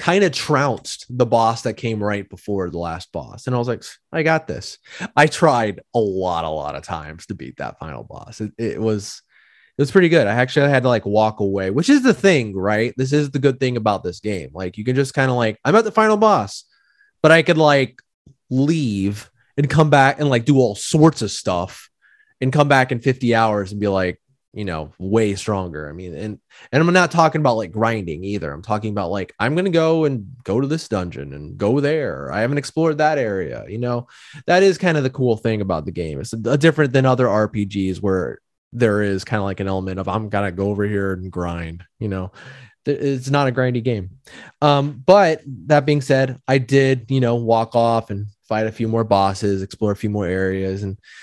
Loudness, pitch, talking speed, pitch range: -19 LUFS, 115 Hz, 230 wpm, 100-140 Hz